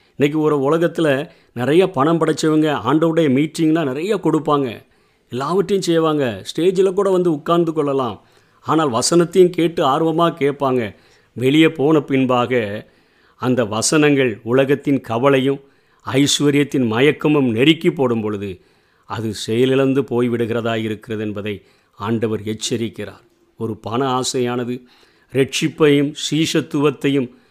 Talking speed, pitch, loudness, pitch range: 100 wpm, 140 Hz, -17 LUFS, 120-155 Hz